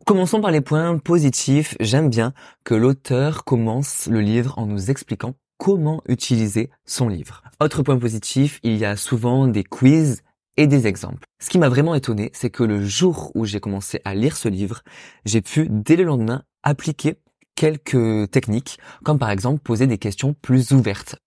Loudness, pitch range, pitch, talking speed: -20 LUFS, 110-145 Hz, 130 Hz, 180 wpm